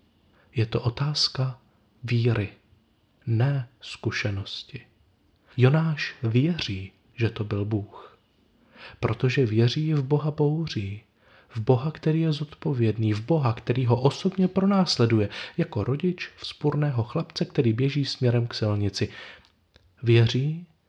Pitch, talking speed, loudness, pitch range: 120 Hz, 110 wpm, -25 LUFS, 105-145 Hz